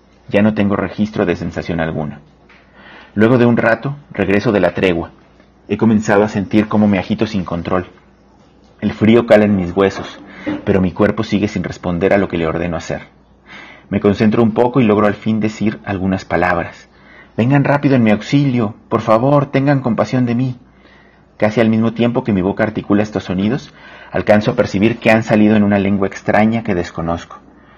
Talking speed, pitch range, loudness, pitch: 185 wpm, 95-110 Hz, -15 LUFS, 105 Hz